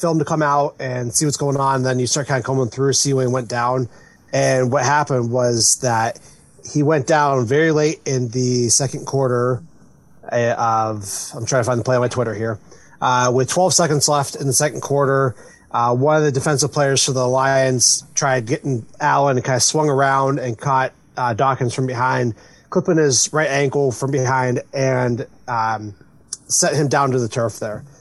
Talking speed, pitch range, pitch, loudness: 200 wpm, 125-145 Hz, 135 Hz, -18 LUFS